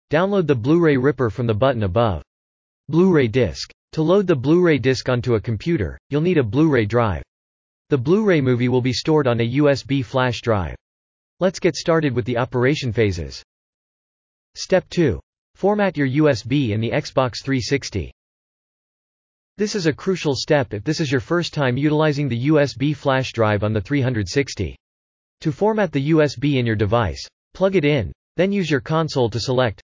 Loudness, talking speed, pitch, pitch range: -20 LUFS, 180 wpm, 130 Hz, 110-155 Hz